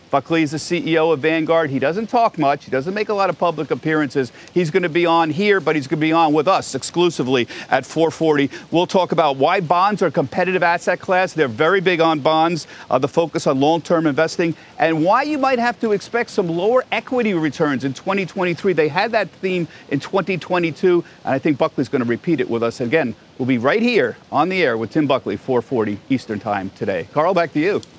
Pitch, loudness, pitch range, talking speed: 165 Hz, -18 LUFS, 150-185 Hz, 225 wpm